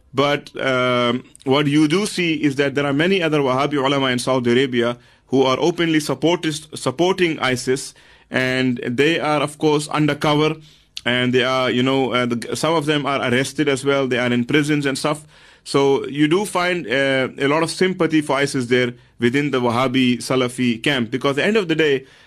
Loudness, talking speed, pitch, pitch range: -19 LUFS, 195 wpm, 140 Hz, 130-150 Hz